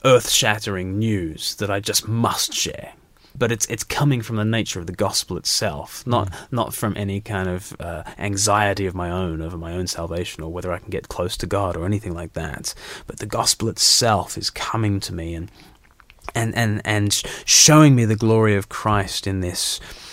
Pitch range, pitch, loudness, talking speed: 90-110 Hz, 100 Hz, -20 LUFS, 195 wpm